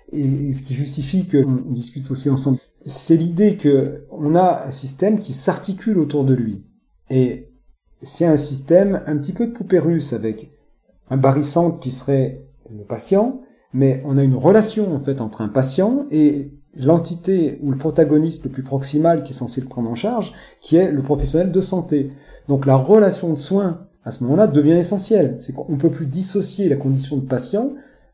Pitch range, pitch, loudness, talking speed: 135-180 Hz, 145 Hz, -18 LUFS, 185 wpm